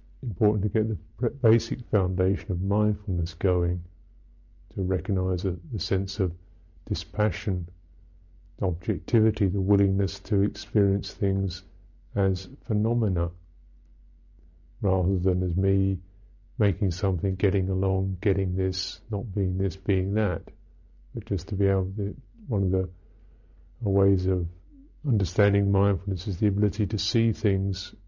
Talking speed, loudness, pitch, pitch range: 125 wpm, -26 LUFS, 95 Hz, 90-105 Hz